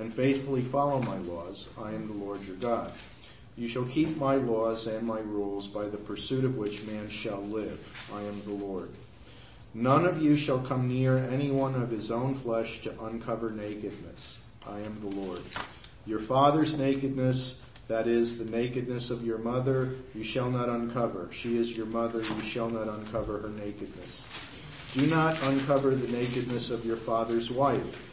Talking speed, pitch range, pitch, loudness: 175 wpm, 110-130 Hz, 115 Hz, -30 LUFS